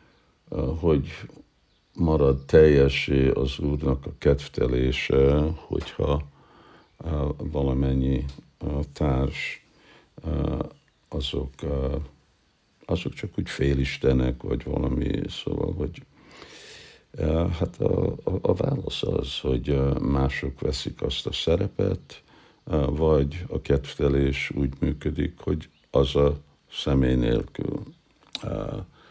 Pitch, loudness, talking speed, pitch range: 70 Hz, -25 LUFS, 80 wpm, 70-75 Hz